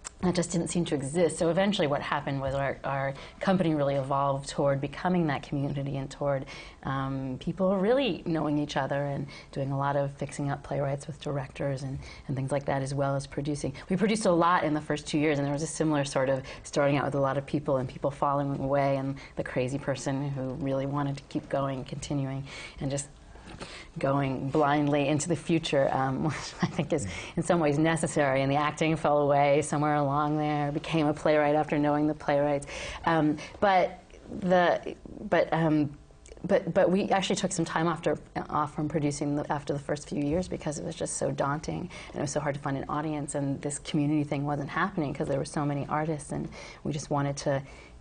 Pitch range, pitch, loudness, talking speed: 140-160 Hz, 145 Hz, -29 LUFS, 215 wpm